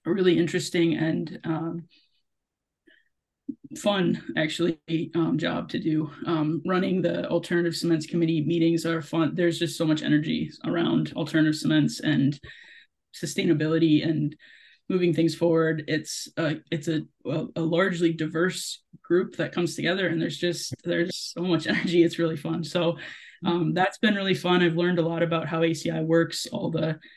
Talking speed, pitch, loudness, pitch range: 160 wpm, 165 Hz, -25 LUFS, 160-175 Hz